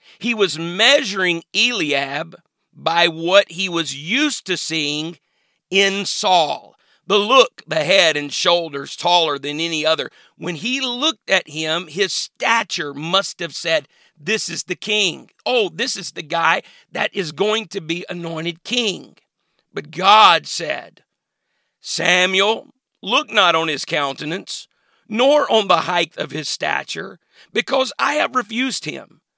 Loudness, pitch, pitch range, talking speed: -18 LUFS, 180 Hz, 165-220 Hz, 145 wpm